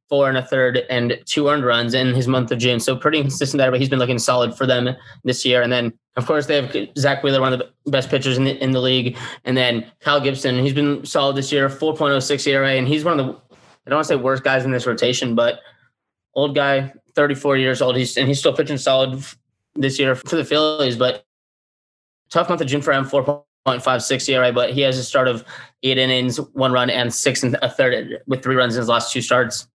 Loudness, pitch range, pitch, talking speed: -19 LUFS, 125-140 Hz, 130 Hz, 255 wpm